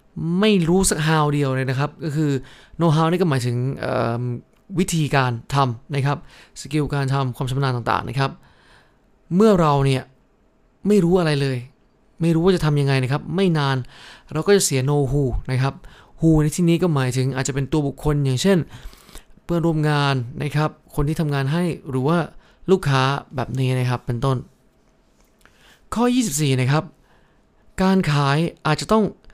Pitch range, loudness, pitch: 135-165 Hz, -20 LUFS, 145 Hz